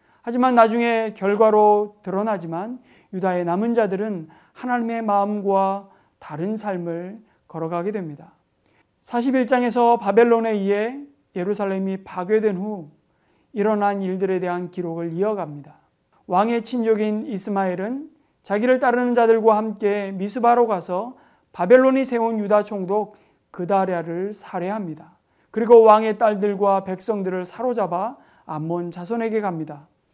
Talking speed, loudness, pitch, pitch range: 290 characters per minute, -21 LUFS, 205 Hz, 185-225 Hz